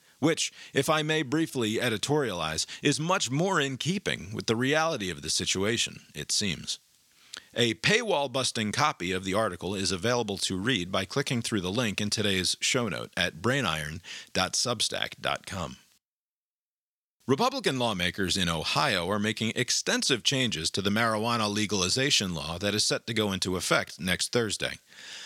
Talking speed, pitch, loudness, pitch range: 150 wpm, 110 Hz, -27 LUFS, 95-135 Hz